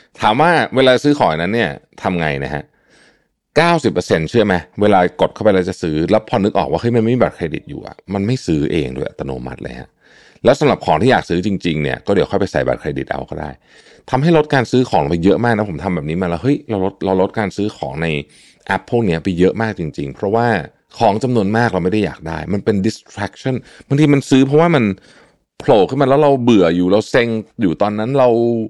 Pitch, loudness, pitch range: 105 Hz, -16 LUFS, 85-120 Hz